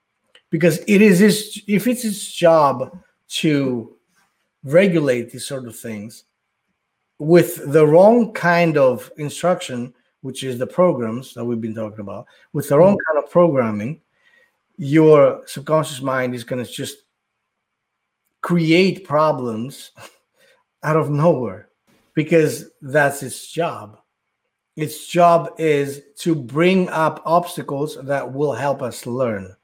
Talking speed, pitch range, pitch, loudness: 130 wpm, 130-175 Hz, 155 Hz, -18 LUFS